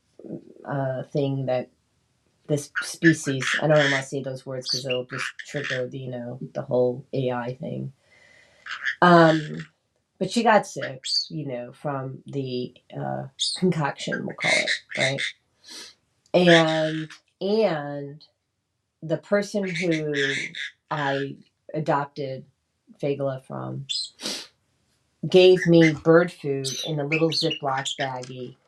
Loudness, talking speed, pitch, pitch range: -24 LUFS, 115 wpm, 140 Hz, 130-160 Hz